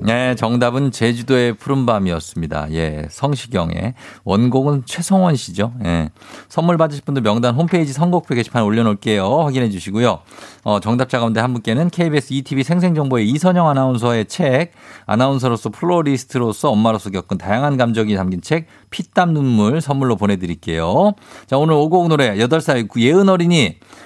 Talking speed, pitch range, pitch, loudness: 370 characters per minute, 105-150 Hz, 125 Hz, -17 LUFS